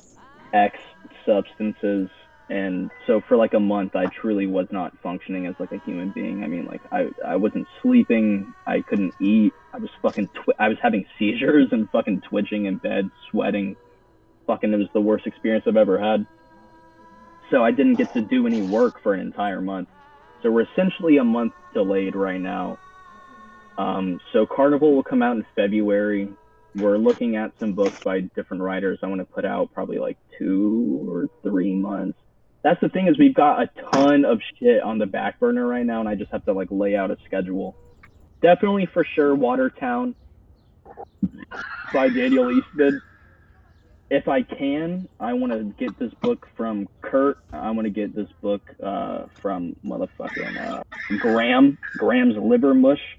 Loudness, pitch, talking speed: -22 LUFS, 120 Hz, 175 wpm